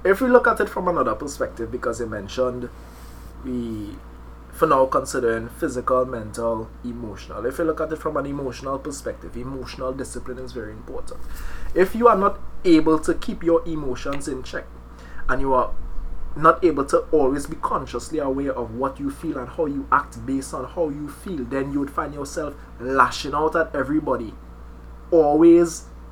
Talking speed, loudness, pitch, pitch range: 175 wpm, -22 LUFS, 130 Hz, 115-155 Hz